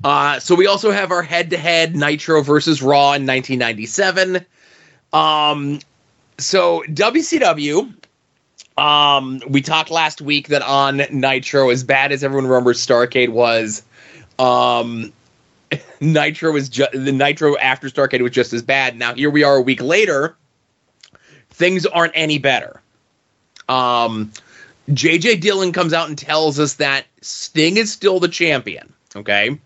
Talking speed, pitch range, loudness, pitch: 140 wpm, 130-165 Hz, -16 LUFS, 145 Hz